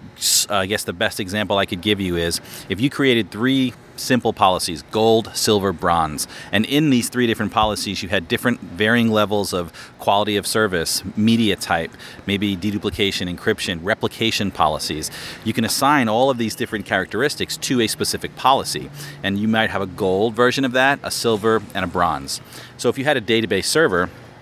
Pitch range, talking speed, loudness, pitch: 100-120 Hz, 185 wpm, -19 LUFS, 110 Hz